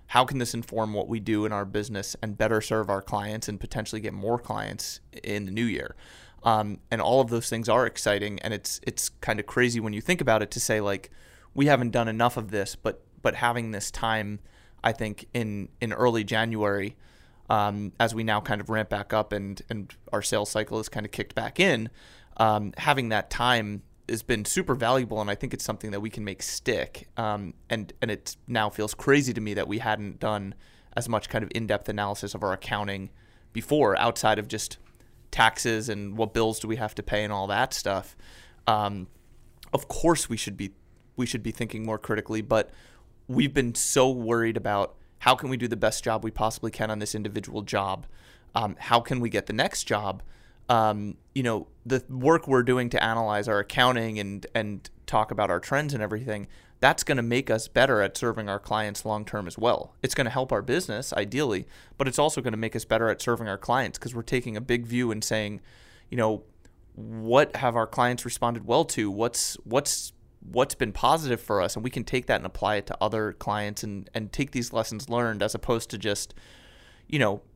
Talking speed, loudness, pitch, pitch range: 215 wpm, -27 LUFS, 110 Hz, 105-120 Hz